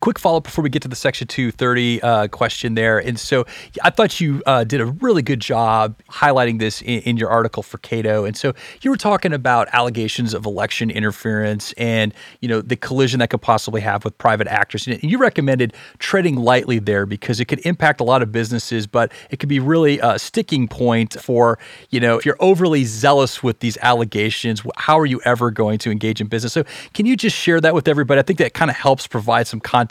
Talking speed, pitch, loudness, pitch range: 225 wpm, 120 Hz, -18 LUFS, 115-145 Hz